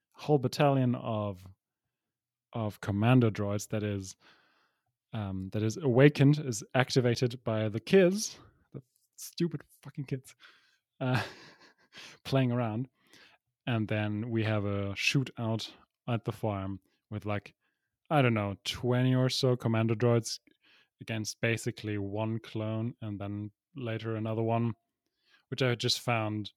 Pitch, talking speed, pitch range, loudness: 115 Hz, 125 wpm, 105-125 Hz, -31 LUFS